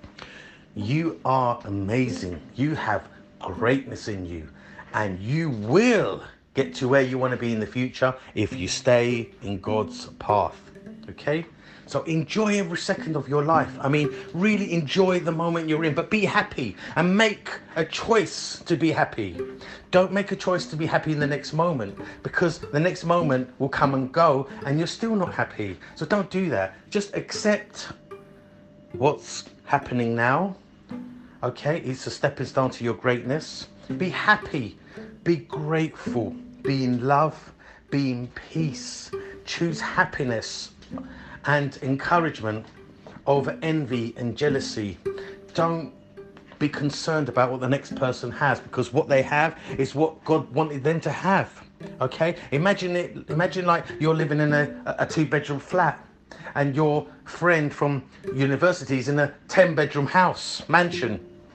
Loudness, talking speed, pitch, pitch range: -25 LUFS, 155 wpm, 145 Hz, 130-175 Hz